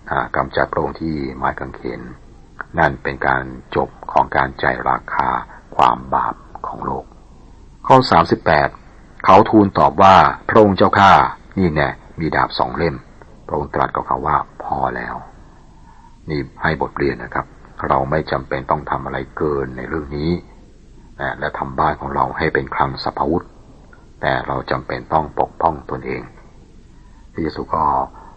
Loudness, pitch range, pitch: -18 LUFS, 65-80 Hz, 70 Hz